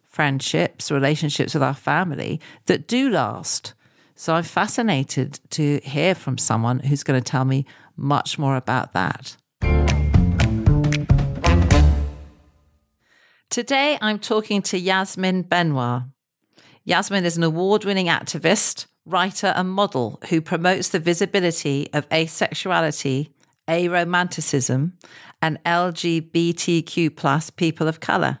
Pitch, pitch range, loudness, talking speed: 160 Hz, 135-180 Hz, -21 LUFS, 110 wpm